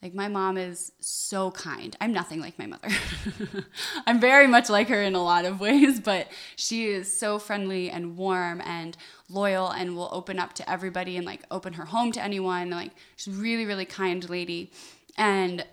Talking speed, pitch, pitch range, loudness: 195 wpm, 190 Hz, 180-210 Hz, -26 LUFS